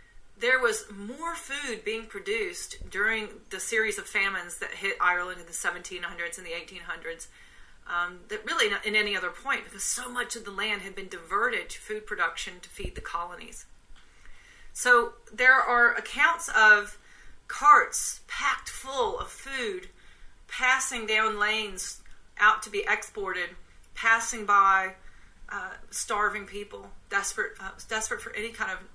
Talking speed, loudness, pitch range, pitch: 150 wpm, -26 LUFS, 195-250 Hz, 215 Hz